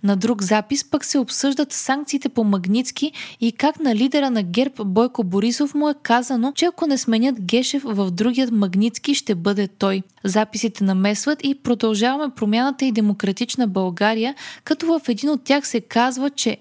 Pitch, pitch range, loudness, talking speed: 240 Hz, 215-280 Hz, -20 LUFS, 170 wpm